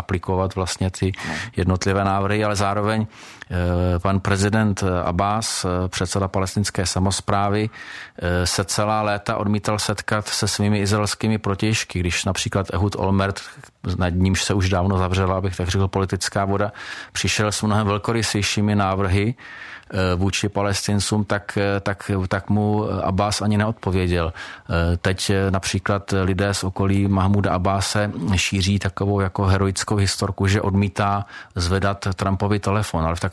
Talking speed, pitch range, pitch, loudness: 125 wpm, 95-105 Hz, 100 Hz, -21 LUFS